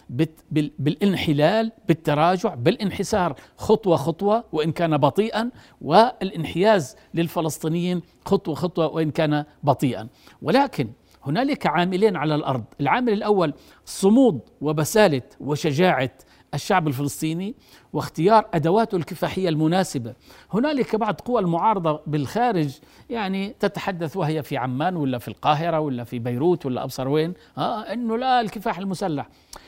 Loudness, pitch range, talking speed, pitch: -22 LUFS, 150-205 Hz, 110 wpm, 170 Hz